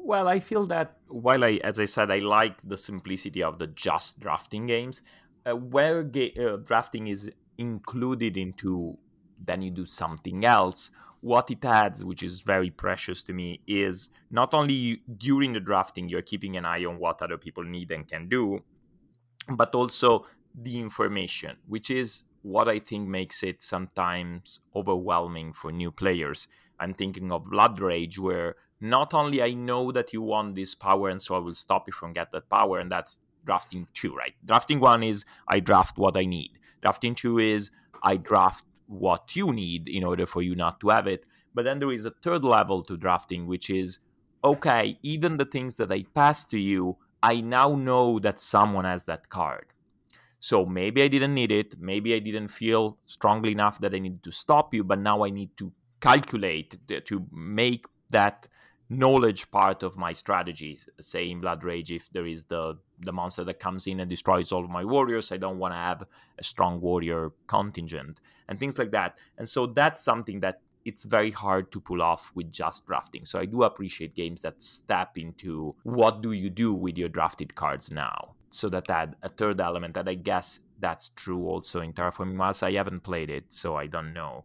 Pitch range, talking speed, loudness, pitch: 90-115 Hz, 195 wpm, -27 LUFS, 95 Hz